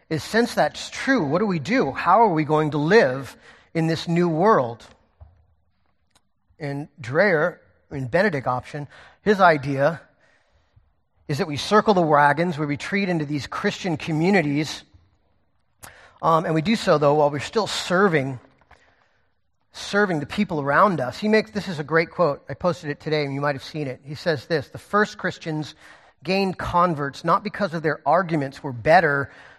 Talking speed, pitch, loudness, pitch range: 170 wpm, 155 Hz, -22 LUFS, 140-185 Hz